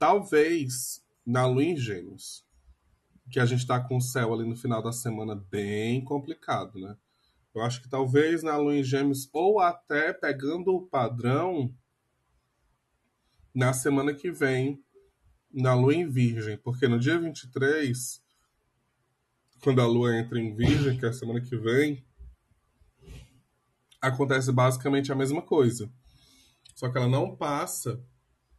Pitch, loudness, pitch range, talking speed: 125 Hz, -27 LUFS, 120-140 Hz, 140 wpm